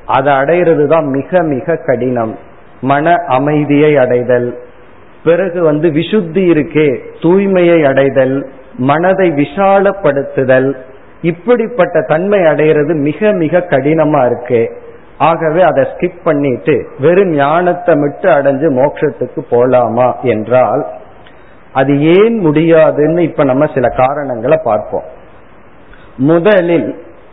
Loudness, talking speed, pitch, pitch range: -11 LUFS, 90 wpm, 155 Hz, 135-175 Hz